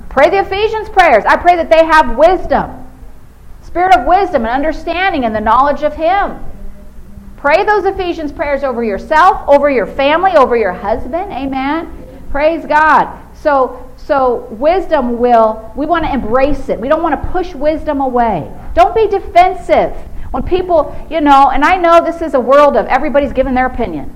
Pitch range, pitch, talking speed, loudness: 265-345 Hz, 305 Hz, 175 wpm, -12 LUFS